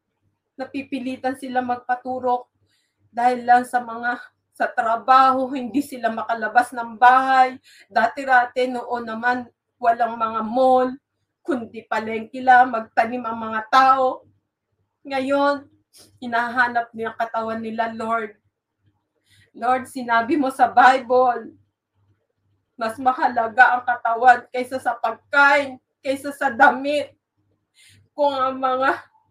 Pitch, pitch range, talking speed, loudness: 245 Hz, 225-260 Hz, 100 wpm, -20 LUFS